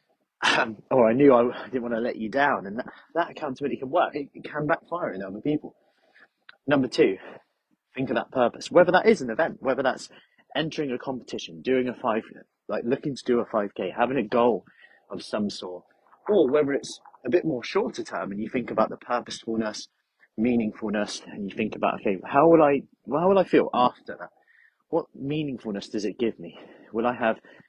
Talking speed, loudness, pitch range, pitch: 200 wpm, -25 LUFS, 110-140 Hz, 120 Hz